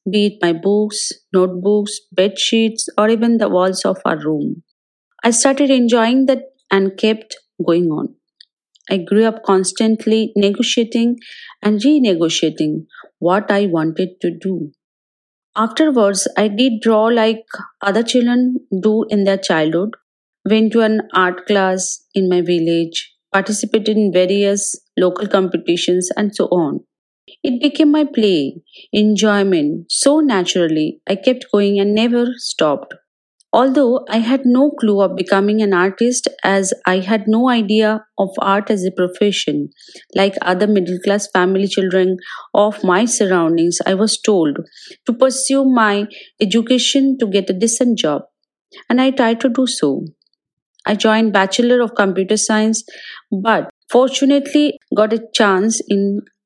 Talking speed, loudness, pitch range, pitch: 140 wpm, -15 LUFS, 190-235 Hz, 210 Hz